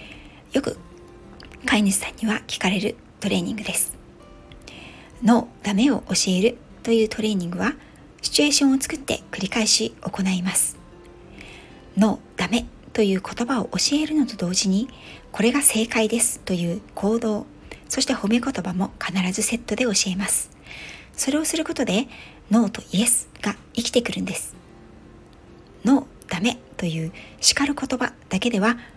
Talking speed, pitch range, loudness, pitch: 300 characters per minute, 195-245 Hz, -22 LUFS, 220 Hz